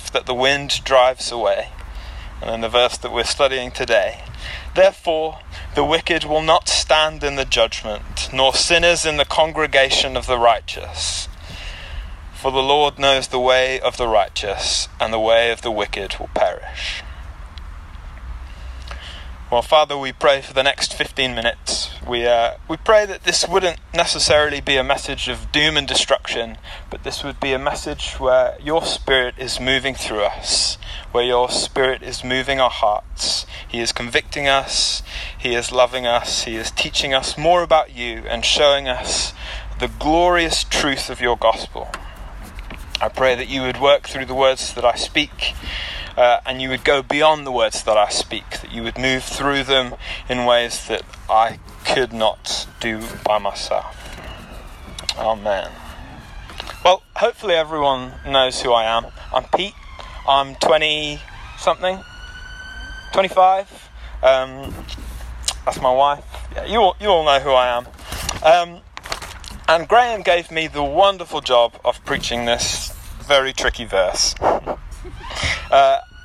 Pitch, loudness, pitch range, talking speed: 130 Hz, -18 LUFS, 115-150 Hz, 155 wpm